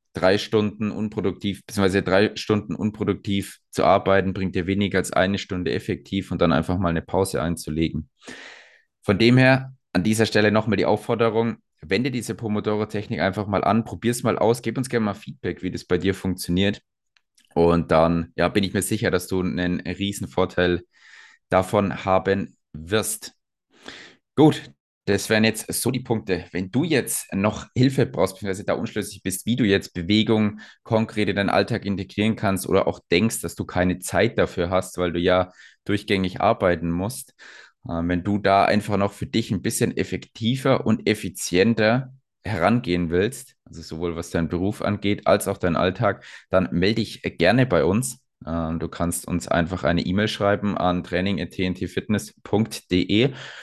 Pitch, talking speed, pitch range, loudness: 100 Hz, 165 wpm, 90-110 Hz, -23 LUFS